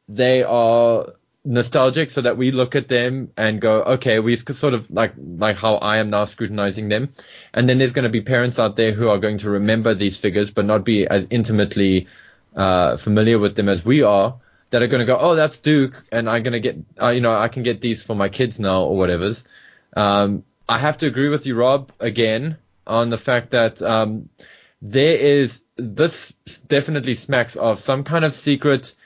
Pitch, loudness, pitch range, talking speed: 115 Hz, -18 LUFS, 105-130 Hz, 210 wpm